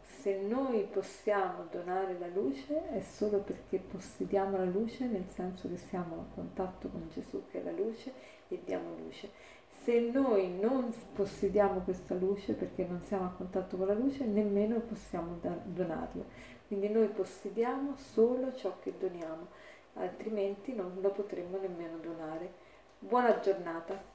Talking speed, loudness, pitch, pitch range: 145 wpm, -35 LUFS, 200 Hz, 185-225 Hz